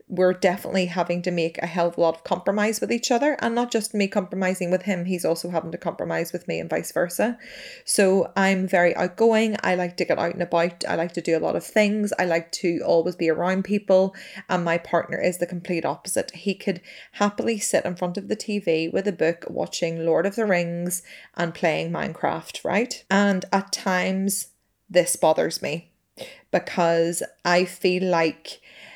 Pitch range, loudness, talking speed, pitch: 170-195 Hz, -23 LUFS, 200 wpm, 180 Hz